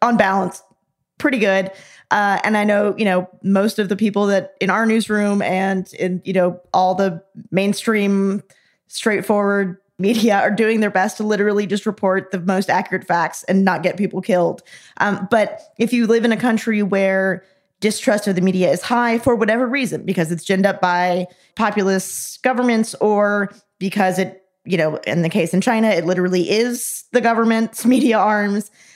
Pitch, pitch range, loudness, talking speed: 200 Hz, 190-220 Hz, -18 LUFS, 180 wpm